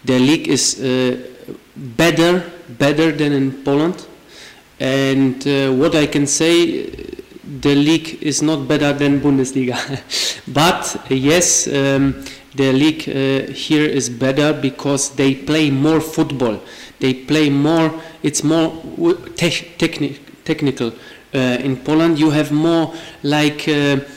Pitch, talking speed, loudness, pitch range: 145 Hz, 130 wpm, -16 LUFS, 135-160 Hz